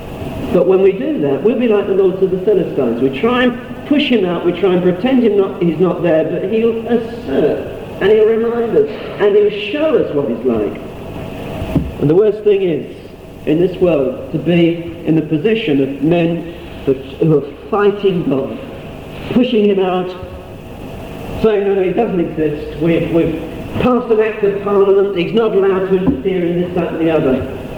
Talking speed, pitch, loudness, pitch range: 185 wpm, 190 Hz, -15 LUFS, 165-225 Hz